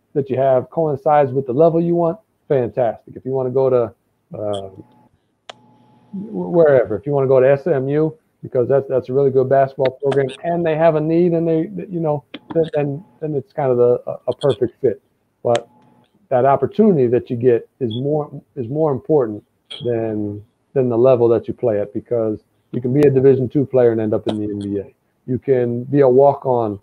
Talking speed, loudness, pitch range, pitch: 200 wpm, -18 LUFS, 120-150 Hz, 130 Hz